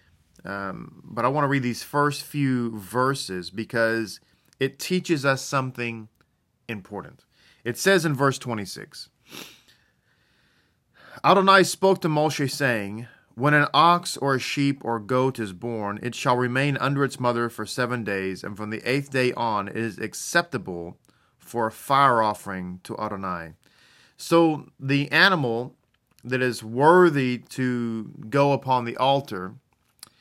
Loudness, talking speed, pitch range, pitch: -23 LUFS, 140 wpm, 110-140 Hz, 125 Hz